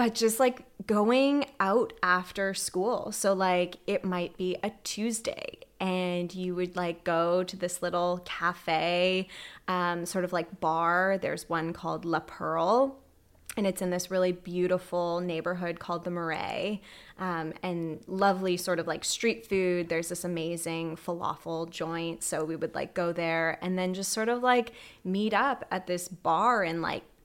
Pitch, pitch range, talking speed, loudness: 180 Hz, 170-195 Hz, 165 wpm, -29 LUFS